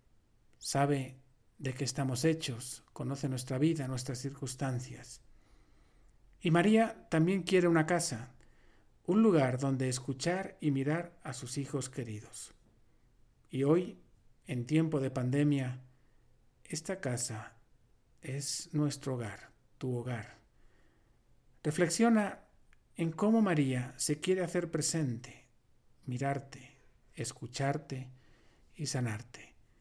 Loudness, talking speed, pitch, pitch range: -33 LUFS, 105 wpm, 135 Hz, 125-155 Hz